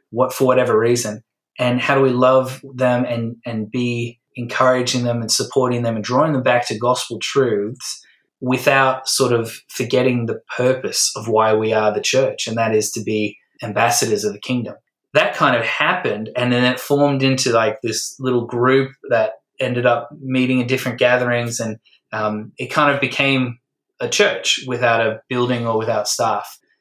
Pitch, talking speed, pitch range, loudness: 125 Hz, 180 wpm, 115-130 Hz, -18 LUFS